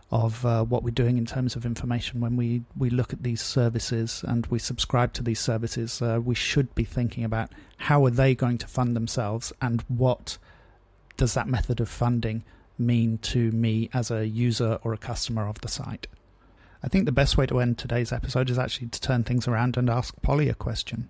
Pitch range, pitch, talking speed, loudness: 115-125 Hz, 120 Hz, 210 wpm, -26 LUFS